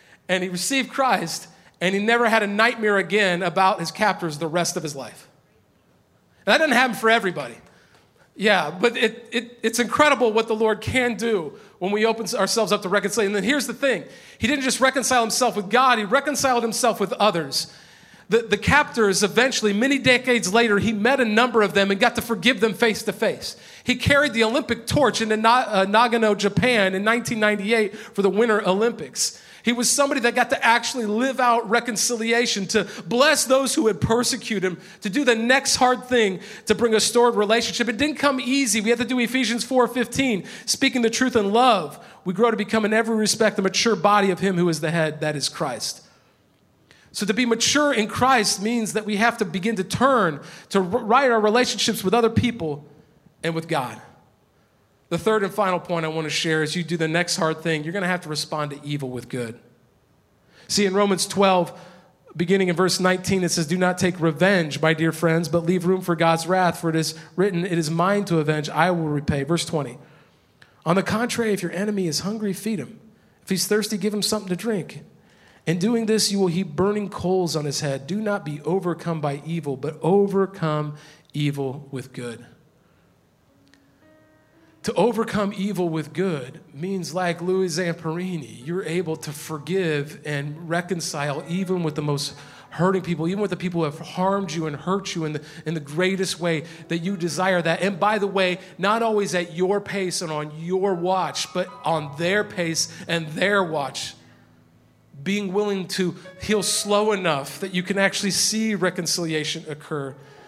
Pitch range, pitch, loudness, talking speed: 165-225 Hz, 195 Hz, -21 LUFS, 195 wpm